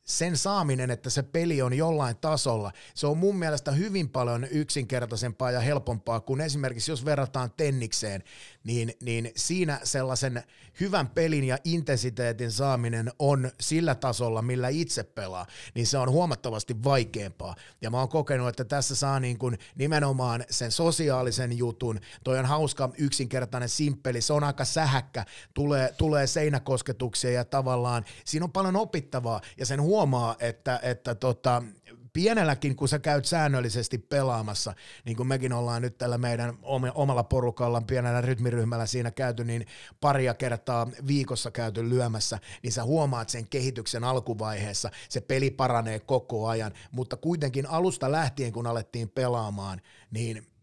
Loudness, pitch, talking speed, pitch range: -28 LUFS, 125 Hz, 145 wpm, 120-140 Hz